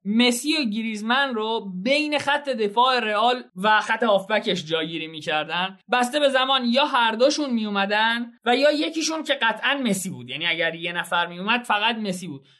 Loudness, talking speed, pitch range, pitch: -22 LUFS, 165 wpm, 190-260 Hz, 225 Hz